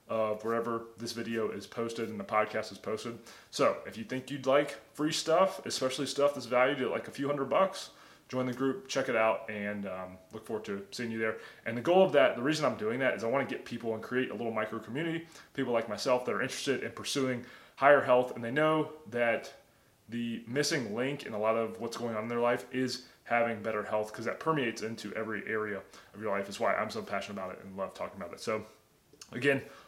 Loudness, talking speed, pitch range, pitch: -32 LUFS, 240 wpm, 110-135 Hz, 120 Hz